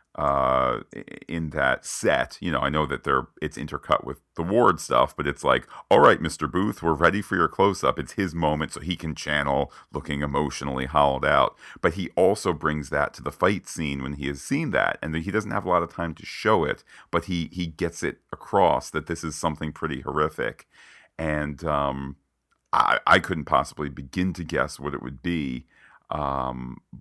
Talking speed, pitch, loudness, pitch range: 205 wpm, 75 Hz, -25 LUFS, 70-85 Hz